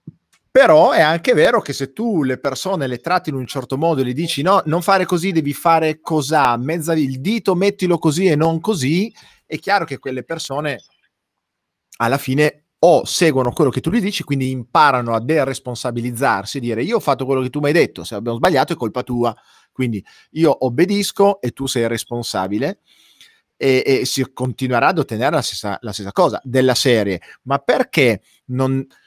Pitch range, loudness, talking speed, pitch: 125-165 Hz, -17 LUFS, 185 wpm, 135 Hz